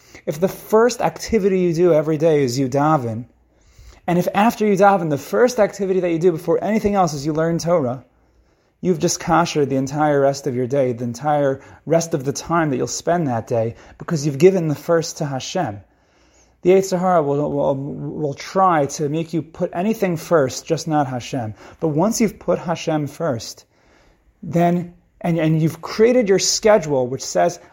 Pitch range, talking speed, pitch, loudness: 140-185 Hz, 185 wpm, 165 Hz, -19 LUFS